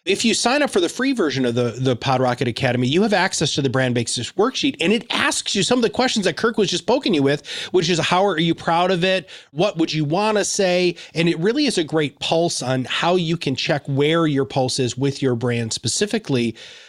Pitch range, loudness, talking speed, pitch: 130-195 Hz, -19 LUFS, 250 wpm, 165 Hz